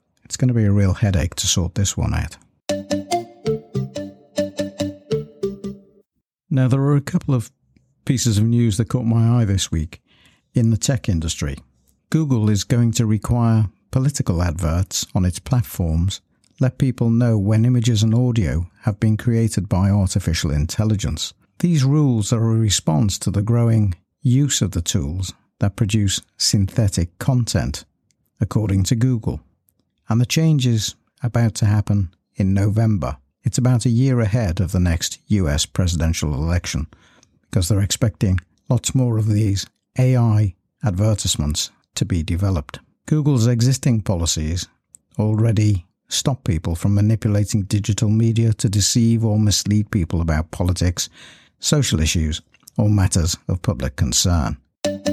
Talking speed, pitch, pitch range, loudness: 140 wpm, 105 Hz, 90-120 Hz, -20 LUFS